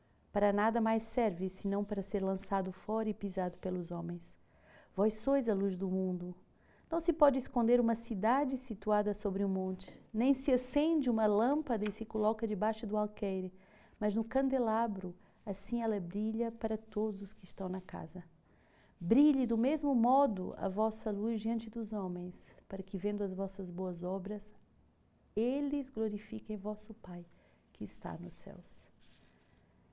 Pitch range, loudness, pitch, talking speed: 190-230 Hz, -35 LUFS, 210 Hz, 155 wpm